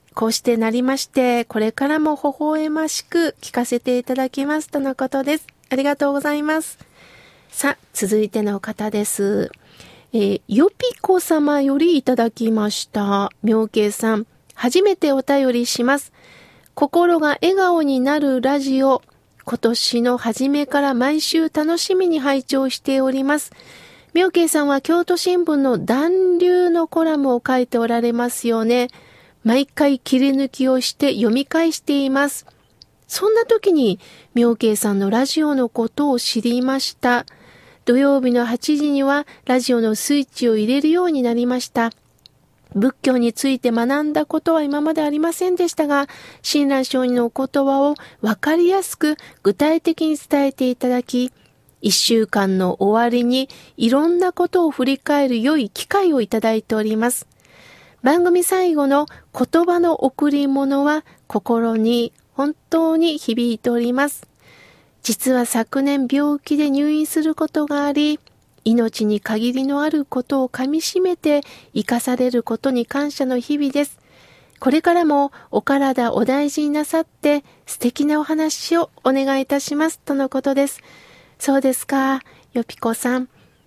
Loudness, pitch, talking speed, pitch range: -19 LUFS, 275 Hz, 290 characters per minute, 240-300 Hz